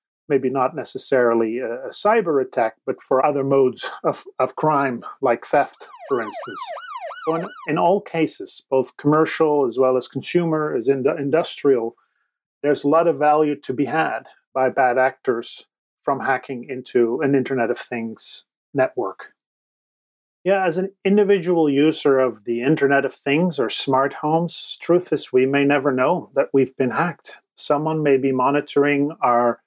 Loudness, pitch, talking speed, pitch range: -20 LUFS, 145 Hz, 160 wpm, 130-160 Hz